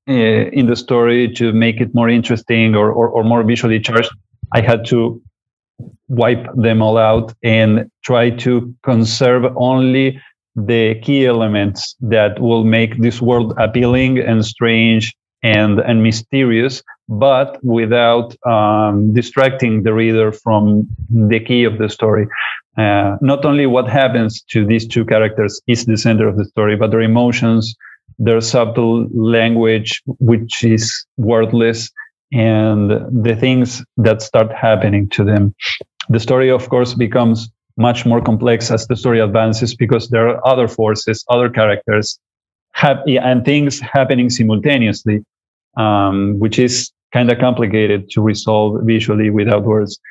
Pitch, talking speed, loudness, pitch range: 115 Hz, 145 wpm, -14 LUFS, 110-120 Hz